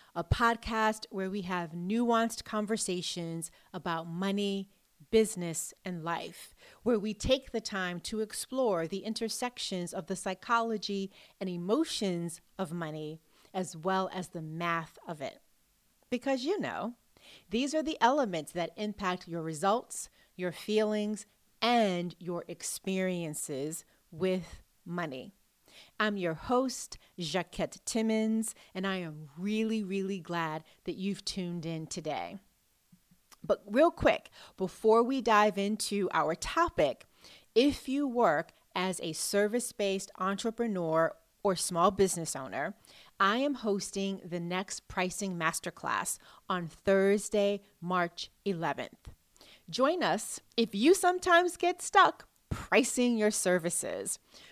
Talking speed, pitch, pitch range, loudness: 120 wpm, 195 Hz, 175-225 Hz, -32 LUFS